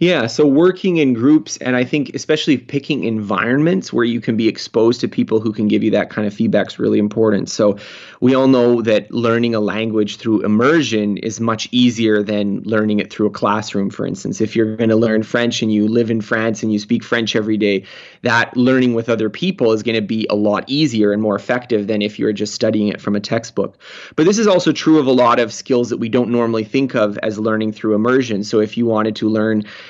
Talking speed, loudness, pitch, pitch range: 235 wpm, -16 LUFS, 110 Hz, 105-125 Hz